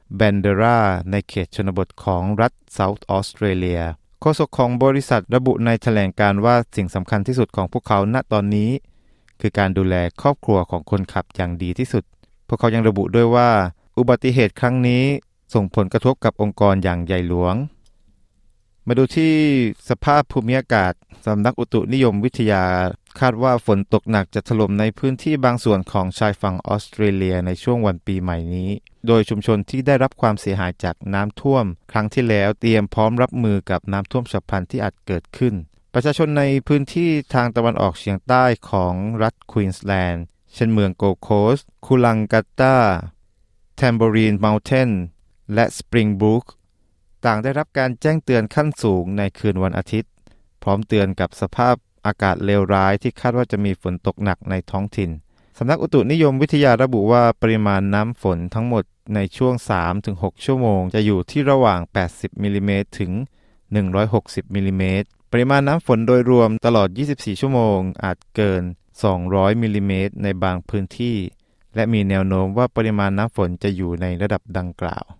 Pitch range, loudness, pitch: 95-120 Hz, -19 LUFS, 105 Hz